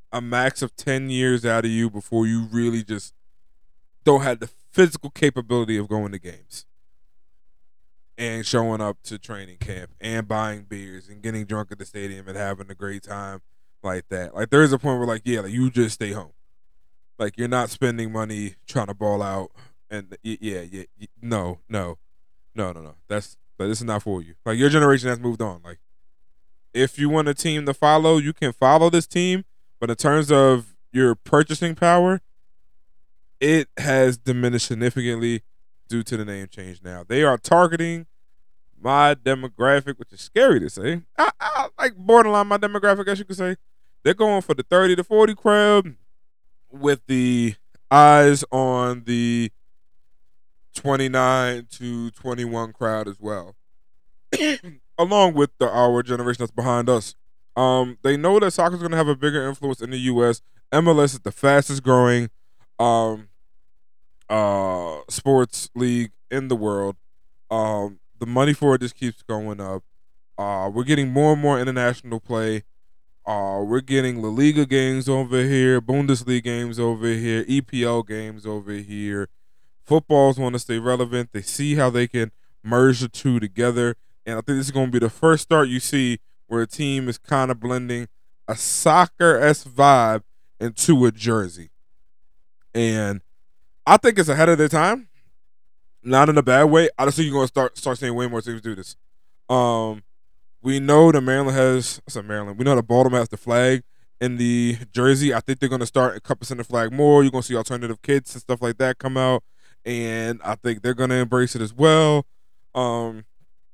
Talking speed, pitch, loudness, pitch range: 180 wpm, 120 Hz, -20 LUFS, 105-135 Hz